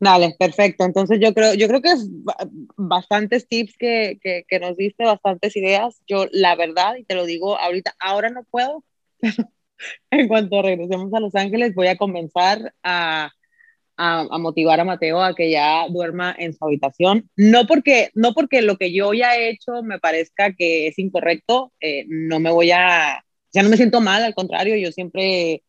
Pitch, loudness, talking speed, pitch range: 195 Hz, -18 LUFS, 190 wpm, 175-225 Hz